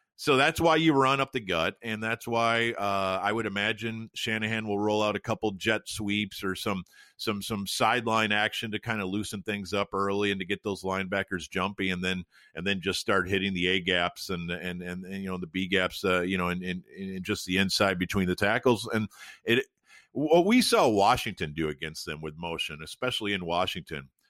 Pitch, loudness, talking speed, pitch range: 100 Hz, -28 LUFS, 215 wpm, 90-110 Hz